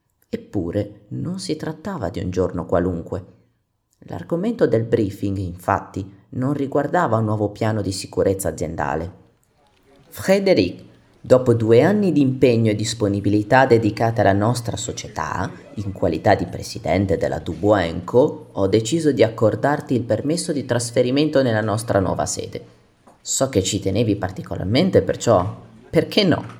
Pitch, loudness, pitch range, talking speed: 110 Hz, -20 LUFS, 95-130 Hz, 135 wpm